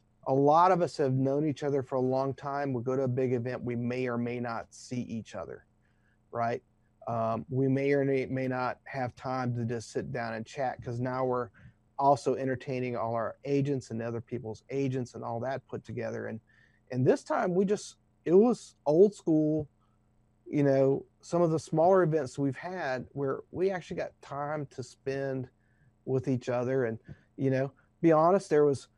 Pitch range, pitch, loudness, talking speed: 115-140 Hz, 130 Hz, -30 LUFS, 195 wpm